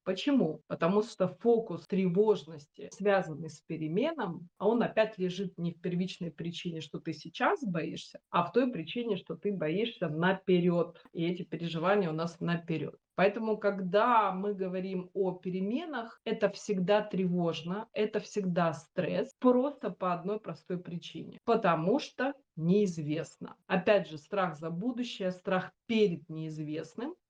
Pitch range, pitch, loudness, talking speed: 170-210 Hz, 185 Hz, -32 LUFS, 135 wpm